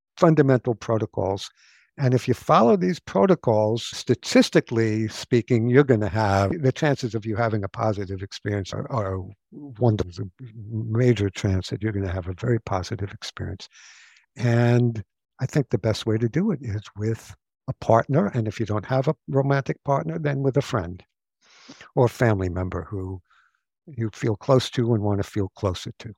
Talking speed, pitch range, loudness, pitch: 175 wpm, 100-130 Hz, -23 LUFS, 115 Hz